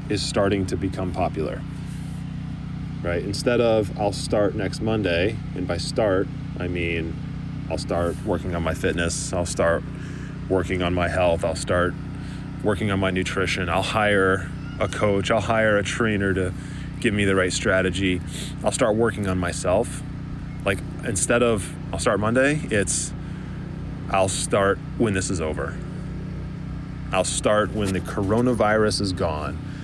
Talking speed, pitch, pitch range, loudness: 150 wpm, 100 Hz, 95-130 Hz, -24 LUFS